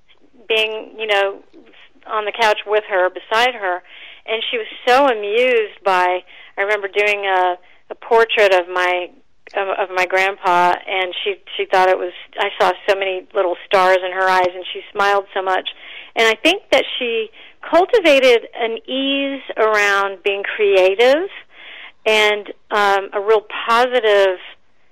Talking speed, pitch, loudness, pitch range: 150 wpm, 205 Hz, -17 LUFS, 185-230 Hz